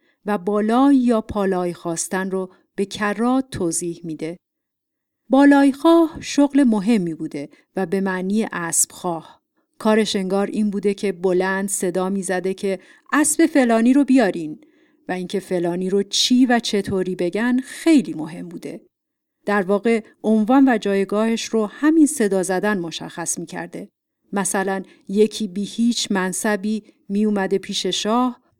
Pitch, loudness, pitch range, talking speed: 205 Hz, -20 LUFS, 185-240 Hz, 130 wpm